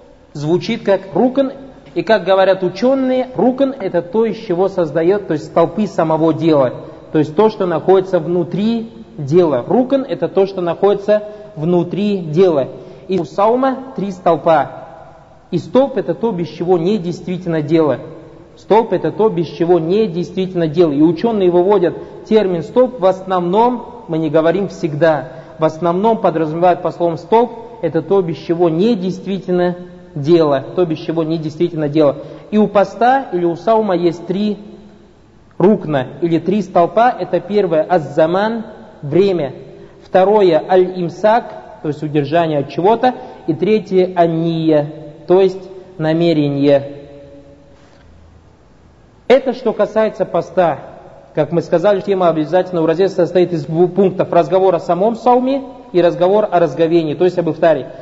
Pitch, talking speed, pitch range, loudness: 180 Hz, 145 wpm, 165-200 Hz, -15 LUFS